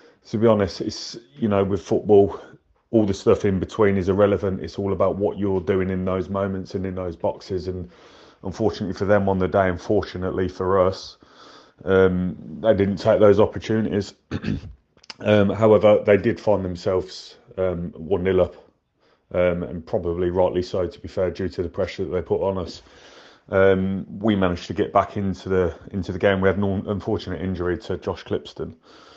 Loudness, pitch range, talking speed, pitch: -22 LUFS, 90-100 Hz, 185 wpm, 95 Hz